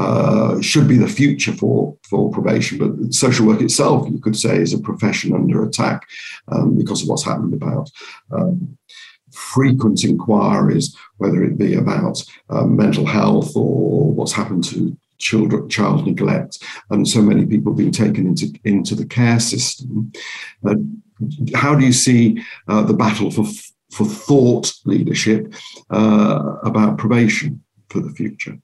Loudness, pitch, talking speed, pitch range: -17 LUFS, 120 Hz, 150 wpm, 110-135 Hz